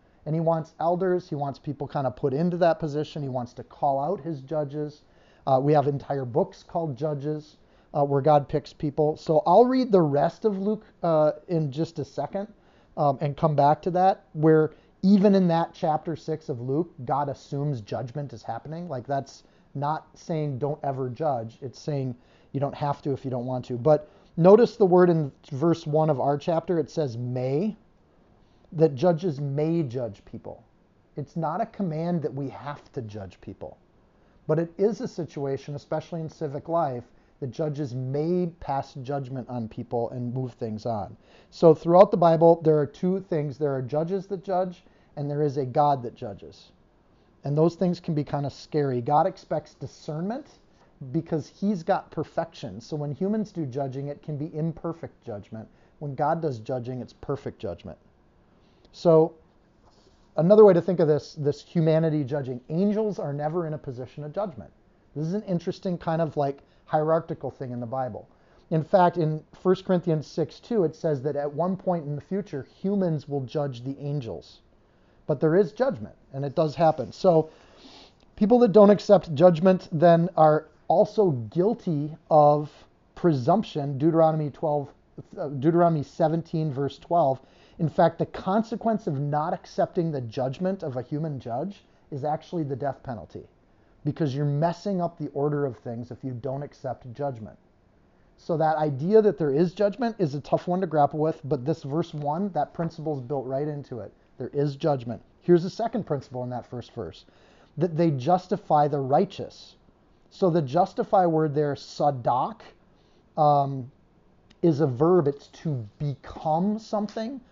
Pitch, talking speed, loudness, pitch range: 155 Hz, 175 wpm, -25 LUFS, 140-175 Hz